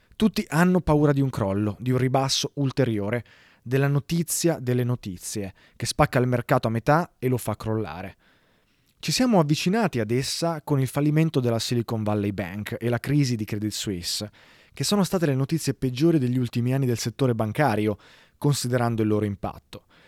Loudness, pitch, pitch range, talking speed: -24 LUFS, 125 Hz, 110-145 Hz, 175 wpm